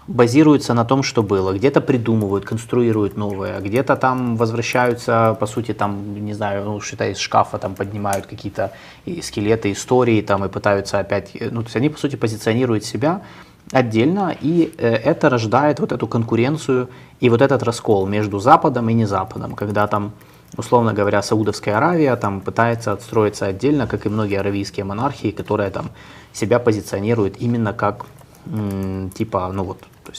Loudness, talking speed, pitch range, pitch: -19 LUFS, 155 wpm, 100-125 Hz, 110 Hz